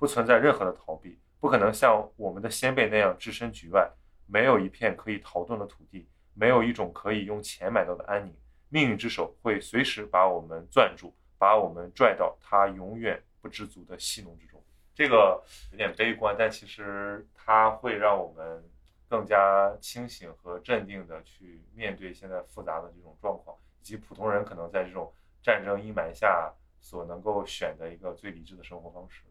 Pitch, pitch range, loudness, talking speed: 95 Hz, 85-105 Hz, -27 LUFS, 285 characters per minute